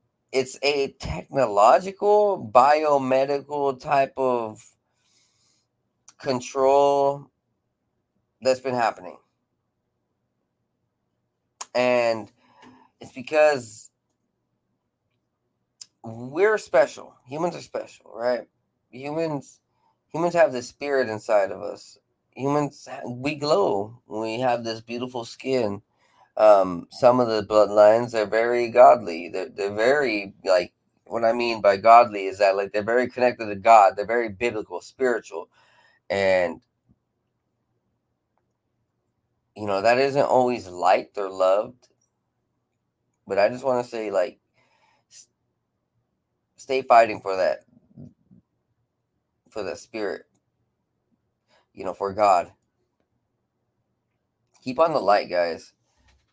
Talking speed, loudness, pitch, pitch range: 105 wpm, -22 LUFS, 120 Hz, 105-135 Hz